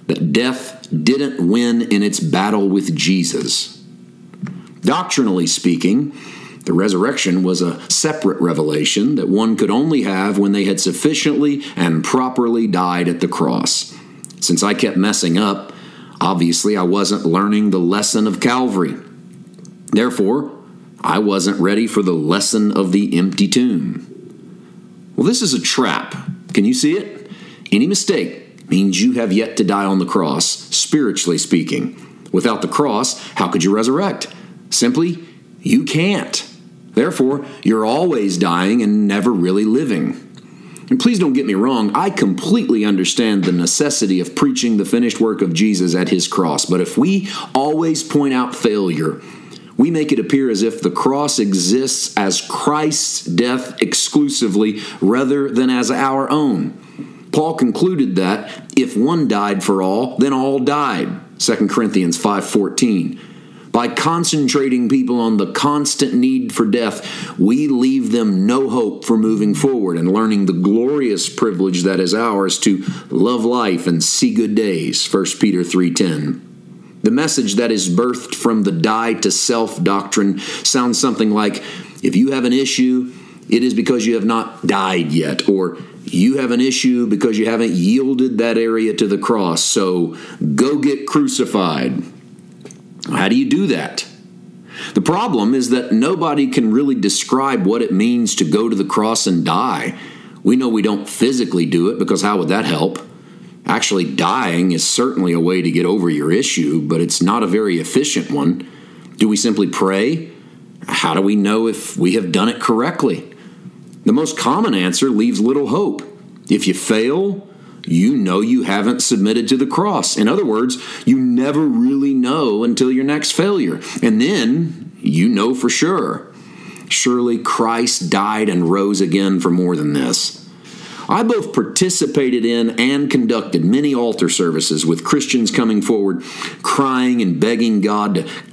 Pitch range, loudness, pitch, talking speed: 95-145 Hz, -16 LUFS, 115 Hz, 160 wpm